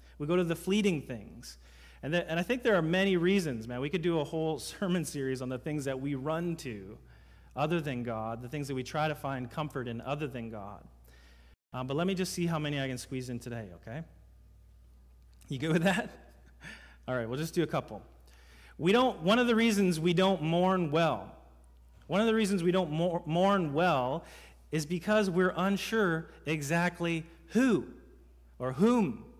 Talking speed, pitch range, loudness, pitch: 200 wpm, 115-180 Hz, -31 LUFS, 155 Hz